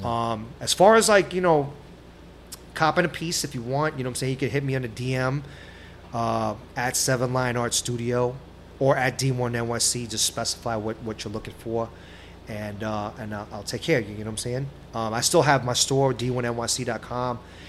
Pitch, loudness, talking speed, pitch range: 120 Hz, -24 LUFS, 210 wpm, 110-130 Hz